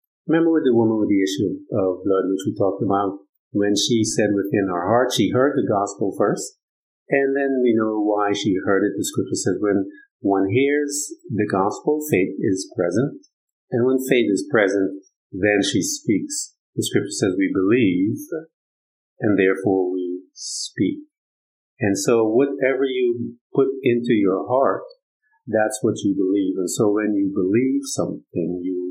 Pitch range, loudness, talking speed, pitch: 100-145 Hz, -21 LUFS, 165 wpm, 115 Hz